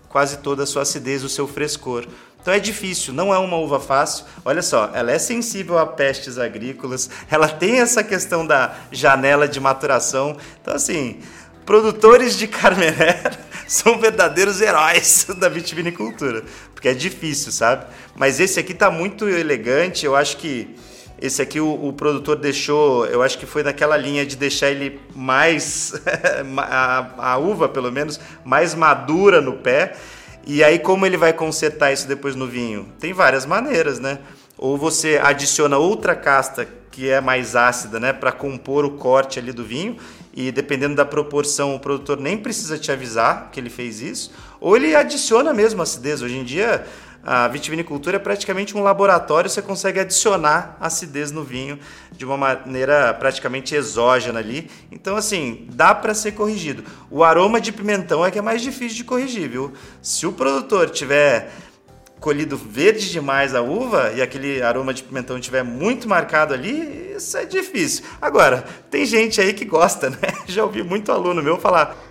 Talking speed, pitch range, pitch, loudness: 170 wpm, 135-195 Hz, 150 Hz, -18 LUFS